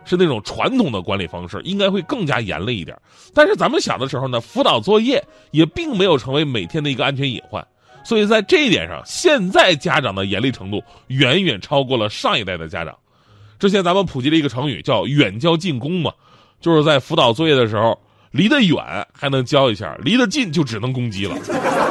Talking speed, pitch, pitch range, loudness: 325 characters per minute, 145 Hz, 115-185 Hz, -17 LUFS